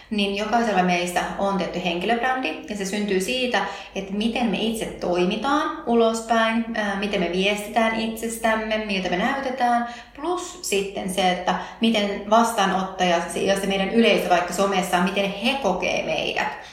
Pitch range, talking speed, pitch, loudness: 190-230 Hz, 145 wpm, 205 Hz, -22 LUFS